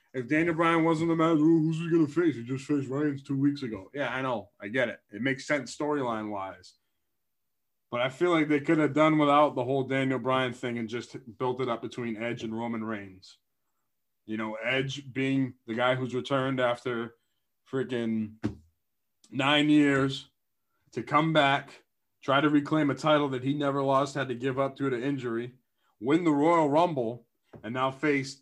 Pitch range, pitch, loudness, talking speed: 120-150 Hz, 135 Hz, -28 LUFS, 190 wpm